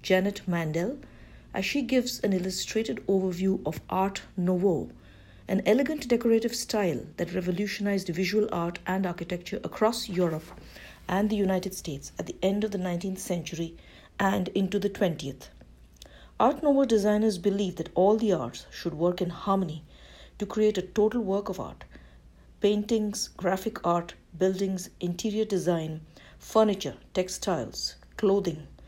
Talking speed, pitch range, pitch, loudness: 135 wpm, 170-205 Hz, 190 Hz, -28 LUFS